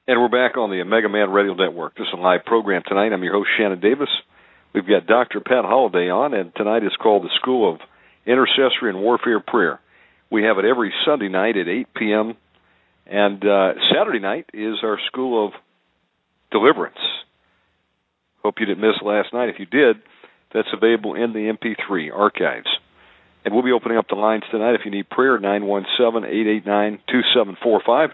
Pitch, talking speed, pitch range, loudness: 105 Hz, 180 wpm, 95-110 Hz, -19 LUFS